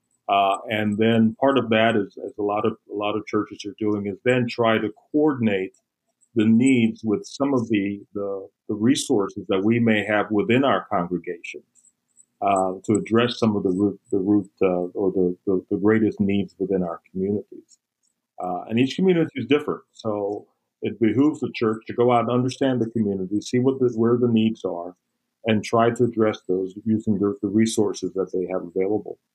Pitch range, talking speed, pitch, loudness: 100-120 Hz, 190 wpm, 110 Hz, -22 LUFS